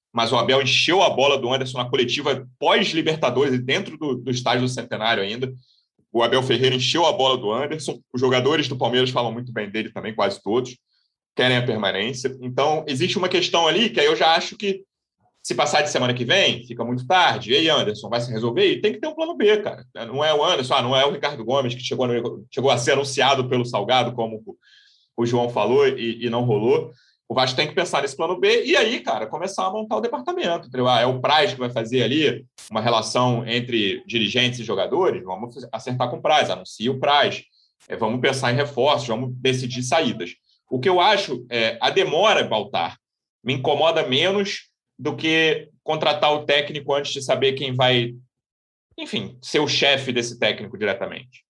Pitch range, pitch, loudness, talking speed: 120-155 Hz, 130 Hz, -21 LUFS, 200 wpm